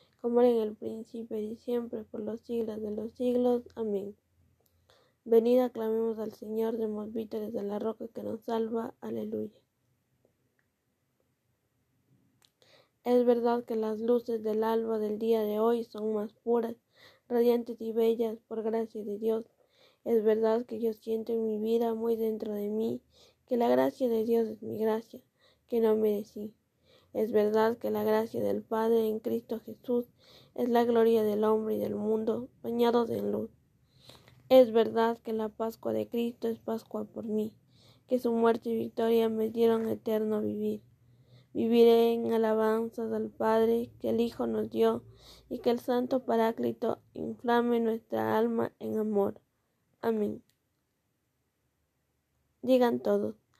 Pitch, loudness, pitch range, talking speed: 225 Hz, -30 LUFS, 215-230 Hz, 150 wpm